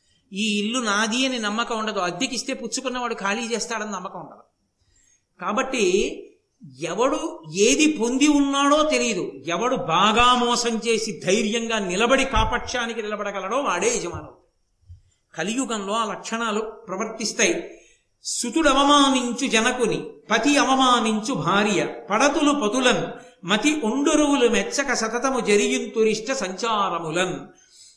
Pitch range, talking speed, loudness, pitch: 210-260 Hz, 100 wpm, -21 LUFS, 230 Hz